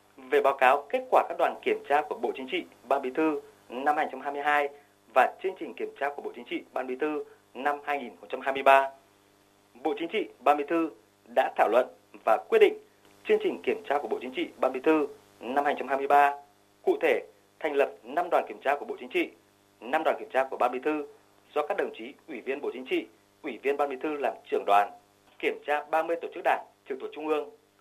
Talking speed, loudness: 225 wpm, -28 LUFS